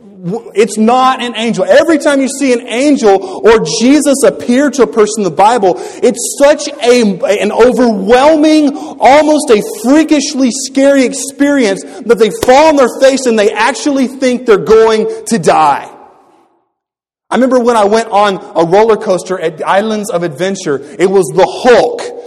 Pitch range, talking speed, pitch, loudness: 210-285 Hz, 165 wpm, 245 Hz, -9 LUFS